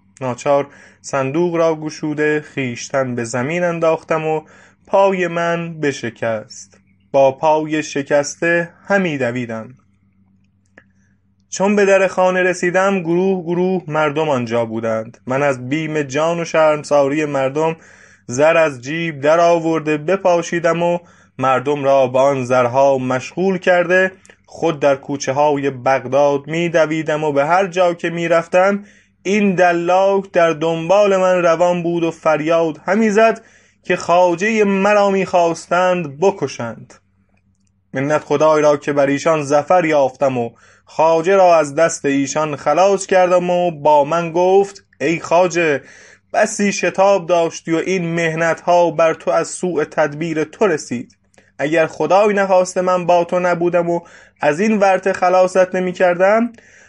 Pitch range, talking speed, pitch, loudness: 140-180 Hz, 135 wpm, 165 Hz, -16 LUFS